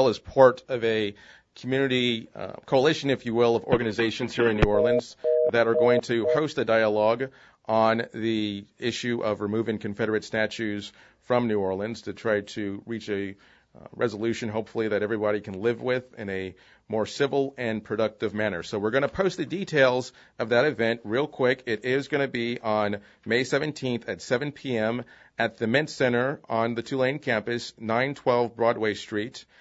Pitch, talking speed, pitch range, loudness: 115 Hz, 175 wpm, 110-125 Hz, -26 LUFS